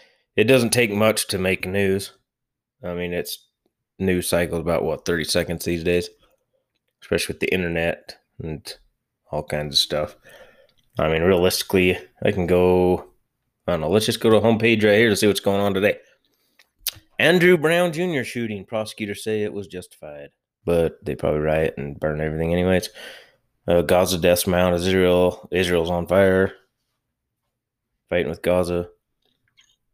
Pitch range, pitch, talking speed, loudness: 85-110 Hz, 90 Hz, 155 wpm, -21 LUFS